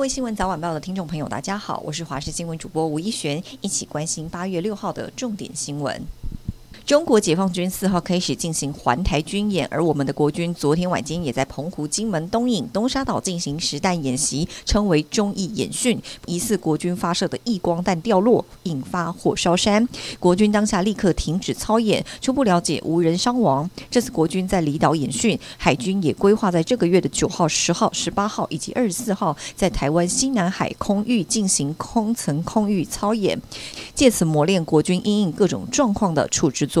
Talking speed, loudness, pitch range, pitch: 305 characters per minute, -21 LUFS, 155-210 Hz, 180 Hz